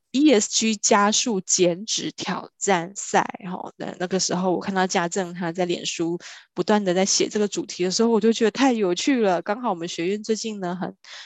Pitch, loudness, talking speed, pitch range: 195 Hz, -22 LUFS, 295 characters per minute, 180-220 Hz